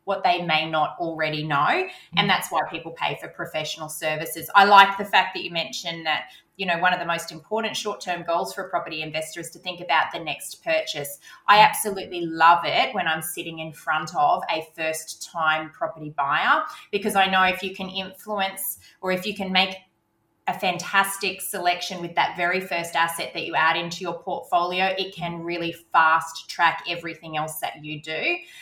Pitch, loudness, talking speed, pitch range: 175 Hz, -23 LUFS, 195 wpm, 160-190 Hz